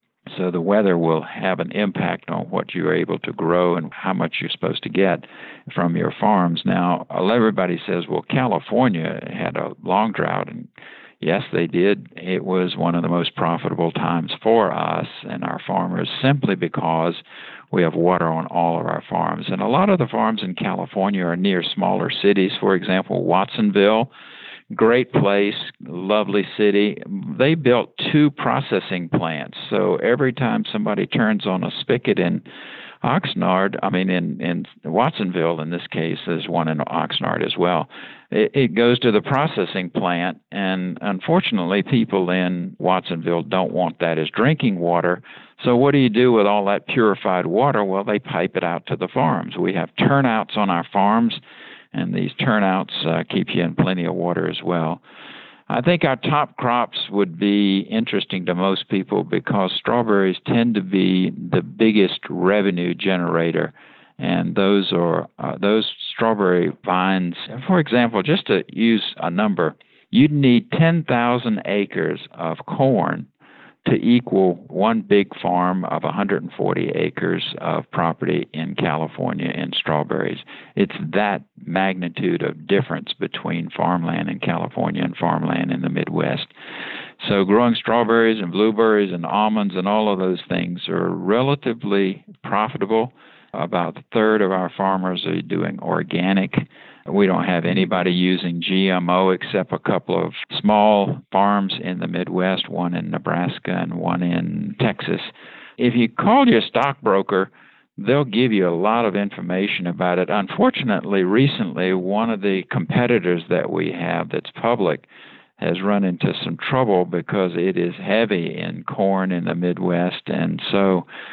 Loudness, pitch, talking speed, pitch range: -20 LUFS, 100 Hz, 155 wpm, 90-115 Hz